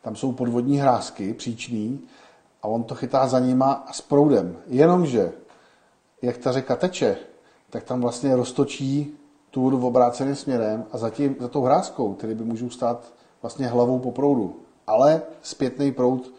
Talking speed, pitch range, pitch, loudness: 160 wpm, 120-140 Hz, 130 Hz, -23 LUFS